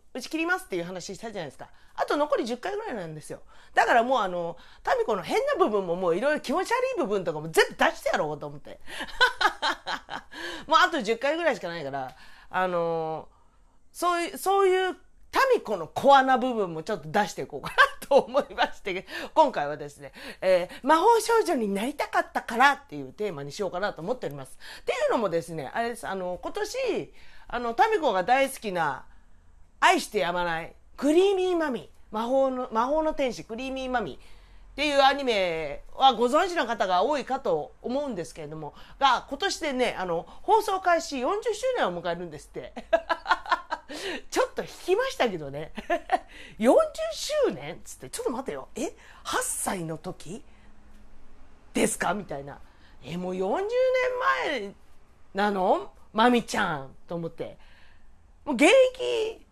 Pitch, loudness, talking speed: 255 Hz, -26 LUFS, 330 characters per minute